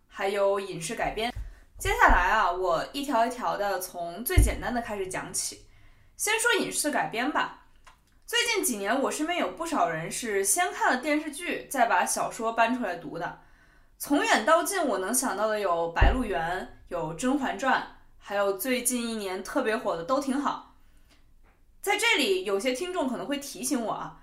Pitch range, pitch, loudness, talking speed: 200-315 Hz, 245 Hz, -27 LUFS, 255 characters per minute